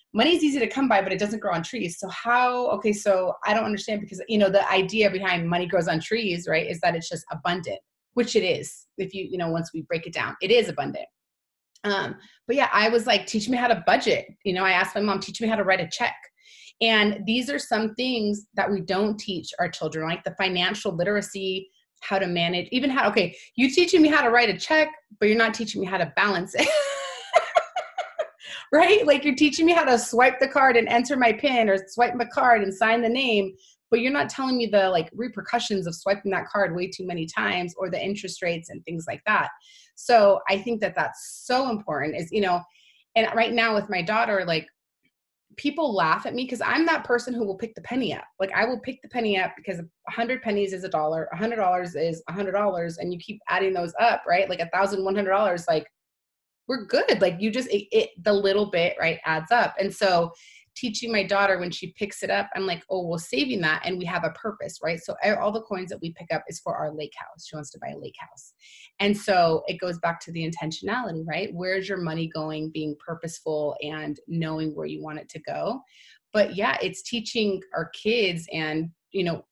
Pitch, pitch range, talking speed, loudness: 200 Hz, 175-235 Hz, 235 wpm, -24 LUFS